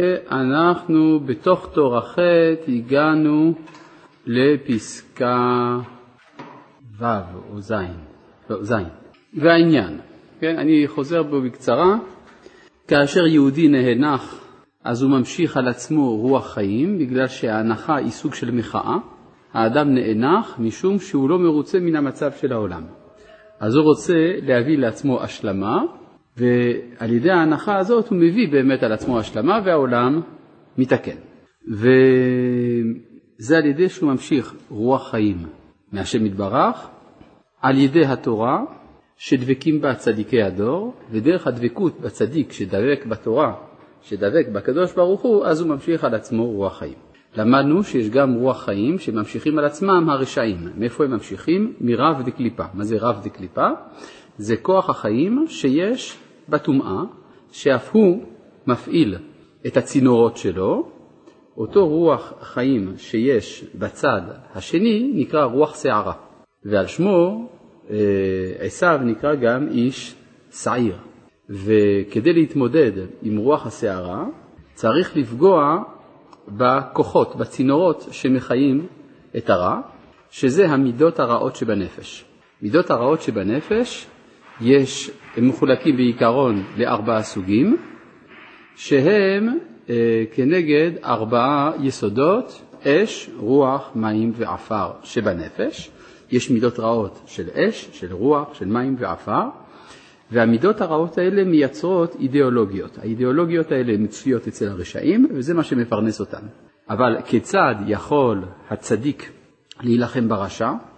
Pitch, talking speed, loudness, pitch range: 130 Hz, 110 wpm, -19 LUFS, 115-160 Hz